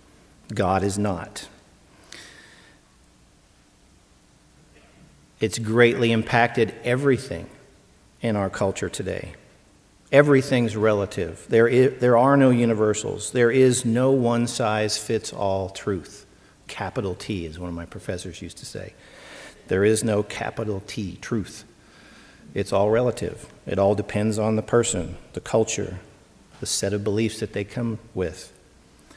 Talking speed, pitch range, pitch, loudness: 130 wpm, 100-120 Hz, 110 Hz, -23 LUFS